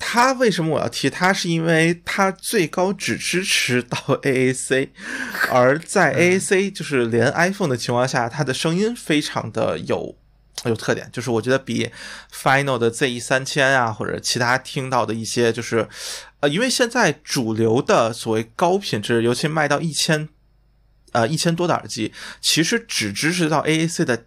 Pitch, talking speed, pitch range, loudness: 140 Hz, 280 characters per minute, 120-170 Hz, -20 LUFS